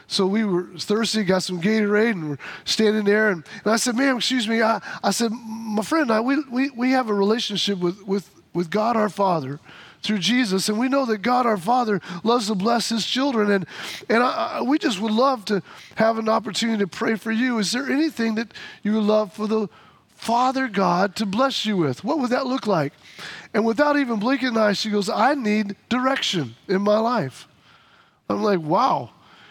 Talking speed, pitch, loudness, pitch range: 210 wpm, 220 Hz, -22 LUFS, 200-245 Hz